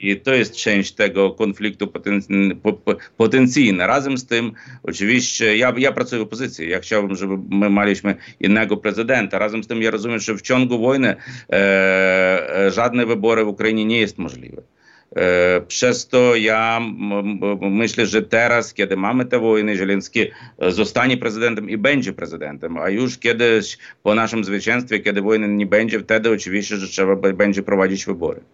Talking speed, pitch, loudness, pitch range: 145 wpm, 110 Hz, -18 LUFS, 100-115 Hz